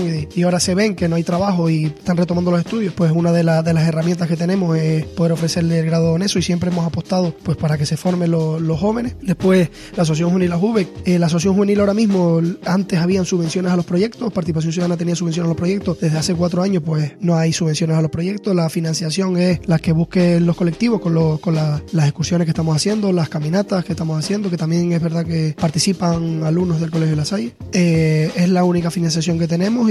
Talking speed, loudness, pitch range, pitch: 235 wpm, -18 LUFS, 165-185 Hz, 170 Hz